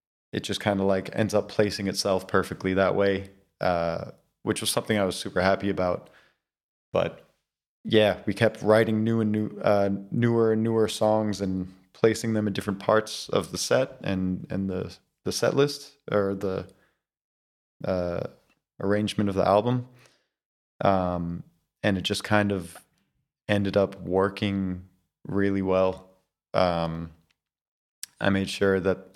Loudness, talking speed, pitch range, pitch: -26 LUFS, 150 wpm, 95-105 Hz, 100 Hz